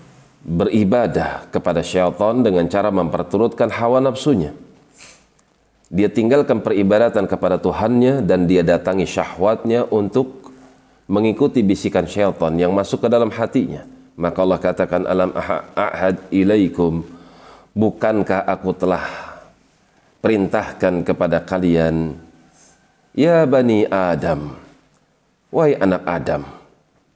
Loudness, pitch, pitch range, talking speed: -18 LUFS, 95 Hz, 90-110 Hz, 95 wpm